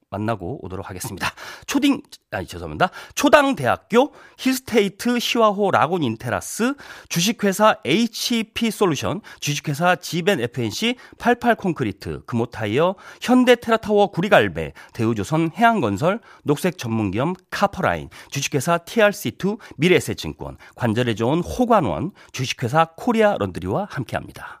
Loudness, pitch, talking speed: -21 LUFS, 185 Hz, 315 characters per minute